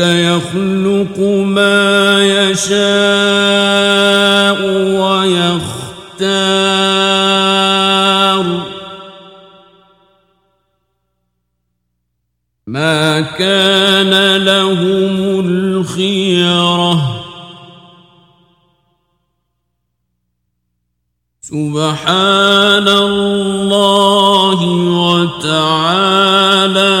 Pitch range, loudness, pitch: 175-195 Hz, -11 LUFS, 190 Hz